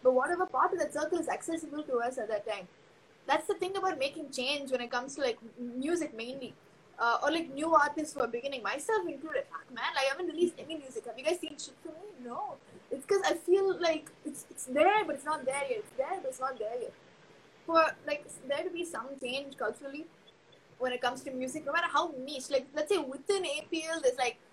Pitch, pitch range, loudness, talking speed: 295 Hz, 265-335 Hz, -33 LUFS, 230 wpm